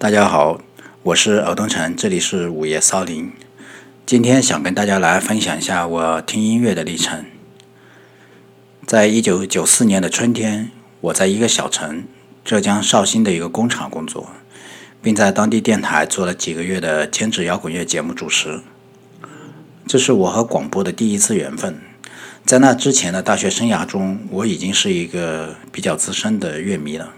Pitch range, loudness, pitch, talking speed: 85-115 Hz, -16 LUFS, 100 Hz, 255 characters per minute